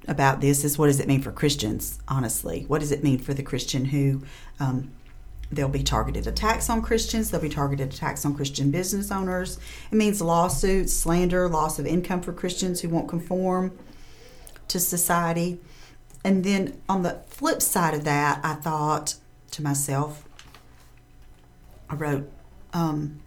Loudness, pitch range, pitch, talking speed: -25 LUFS, 140-180 Hz, 150 Hz, 160 wpm